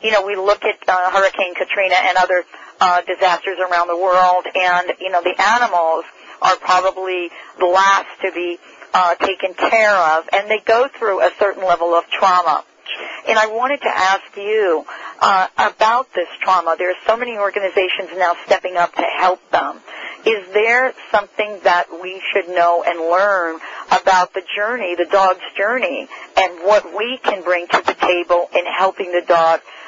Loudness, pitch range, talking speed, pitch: -16 LUFS, 180-210 Hz, 175 wpm, 190 Hz